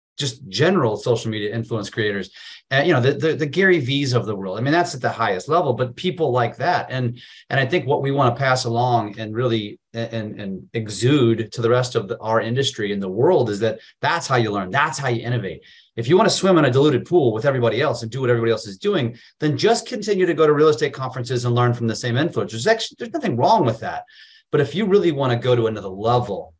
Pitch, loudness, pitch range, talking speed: 125 Hz, -20 LUFS, 115-155 Hz, 255 wpm